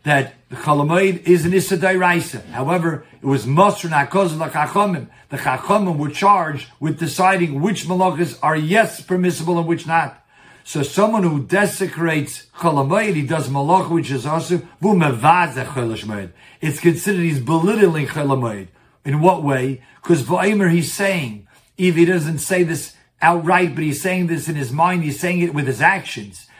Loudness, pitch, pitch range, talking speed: -18 LUFS, 165 Hz, 140-185 Hz, 155 wpm